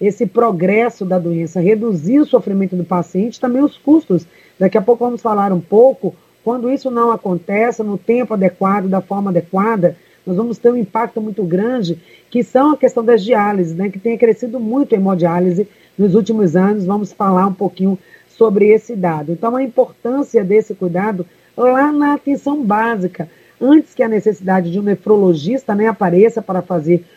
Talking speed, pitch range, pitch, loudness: 175 wpm, 190-235 Hz, 210 Hz, -15 LUFS